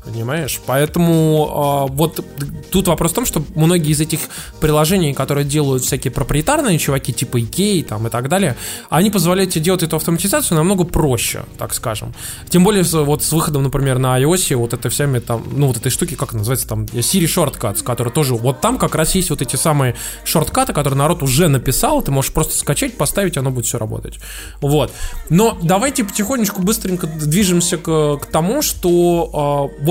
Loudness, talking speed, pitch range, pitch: -16 LUFS, 185 wpm, 130-175 Hz, 150 Hz